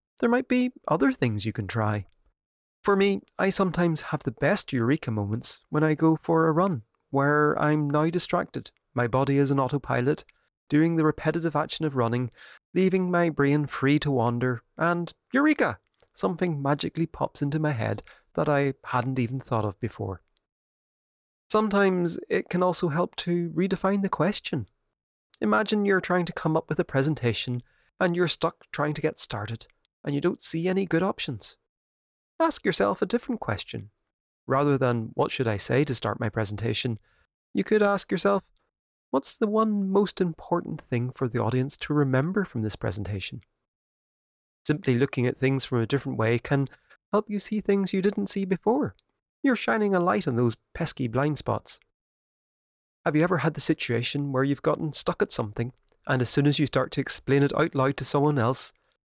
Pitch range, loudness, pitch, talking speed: 125-180 Hz, -26 LUFS, 145 Hz, 180 wpm